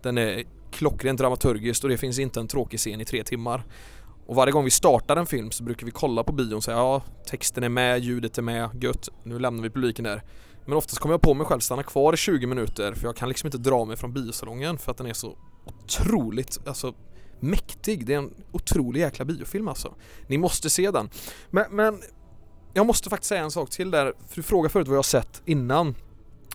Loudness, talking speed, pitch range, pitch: -25 LUFS, 230 wpm, 115-140 Hz, 125 Hz